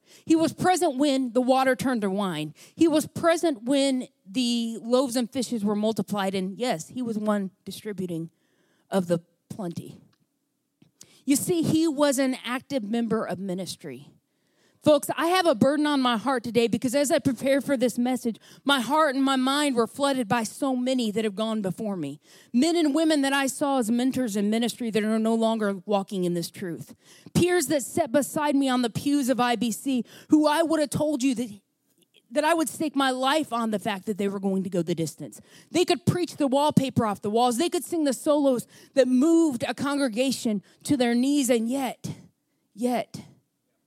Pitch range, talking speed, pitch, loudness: 210-280 Hz, 195 wpm, 250 Hz, -25 LUFS